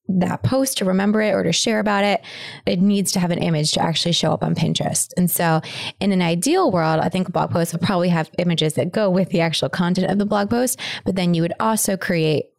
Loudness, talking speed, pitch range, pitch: -19 LUFS, 250 wpm, 165-200 Hz, 180 Hz